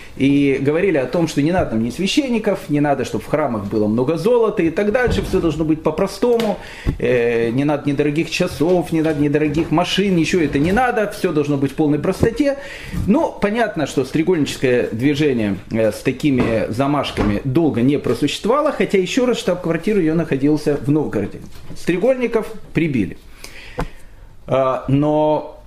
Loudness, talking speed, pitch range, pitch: -18 LUFS, 150 wpm, 135-185 Hz, 150 Hz